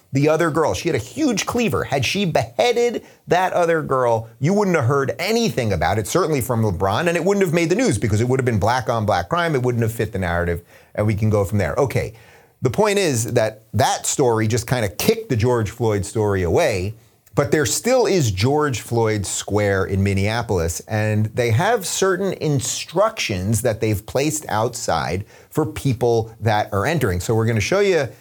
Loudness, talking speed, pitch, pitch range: -20 LUFS, 205 wpm, 120 Hz, 105-155 Hz